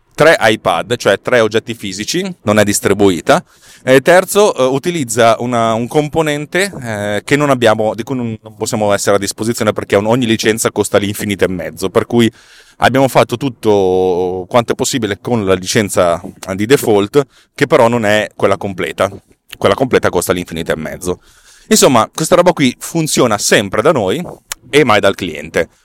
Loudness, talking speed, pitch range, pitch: -13 LUFS, 165 wpm, 105-135 Hz, 115 Hz